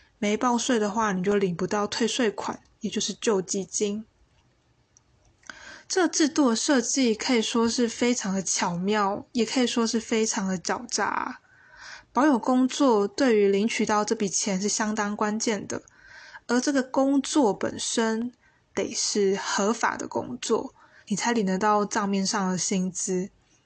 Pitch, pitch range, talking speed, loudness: 220 Hz, 205-245 Hz, 225 characters per minute, -25 LUFS